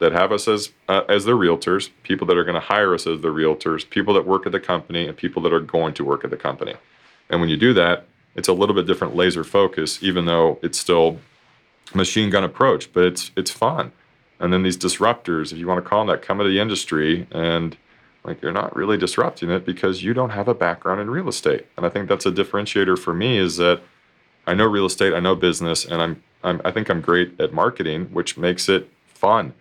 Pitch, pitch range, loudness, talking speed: 90 Hz, 85-100 Hz, -20 LUFS, 240 wpm